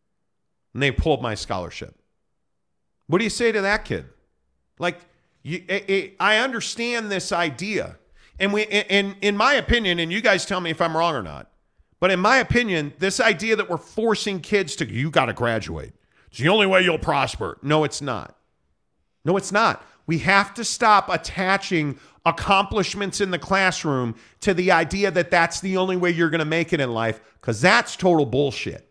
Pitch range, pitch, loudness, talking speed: 155-200 Hz, 180 Hz, -21 LUFS, 185 wpm